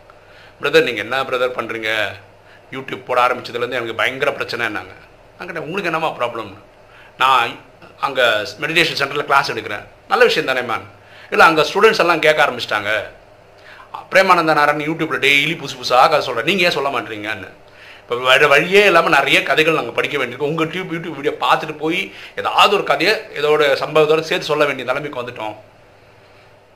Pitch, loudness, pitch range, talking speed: 145 Hz, -16 LUFS, 125-160 Hz, 155 wpm